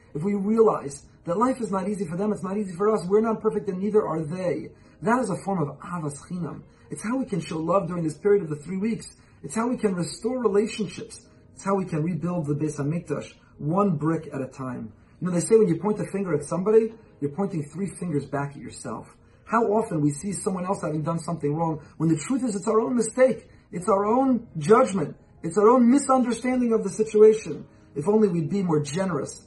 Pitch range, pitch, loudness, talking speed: 155-215 Hz, 190 Hz, -25 LUFS, 230 wpm